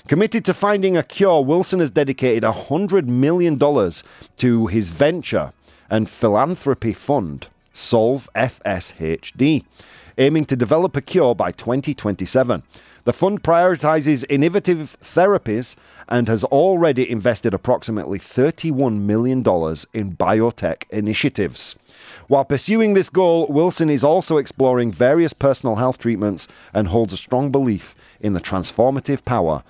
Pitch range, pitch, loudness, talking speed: 110-155 Hz, 130 Hz, -18 LUFS, 125 wpm